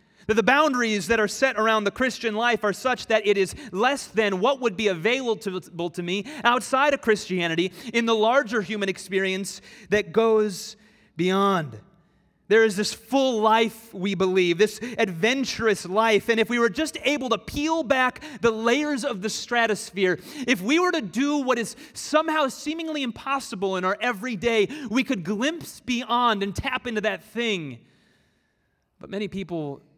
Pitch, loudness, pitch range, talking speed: 225 Hz, -24 LUFS, 200-255 Hz, 165 wpm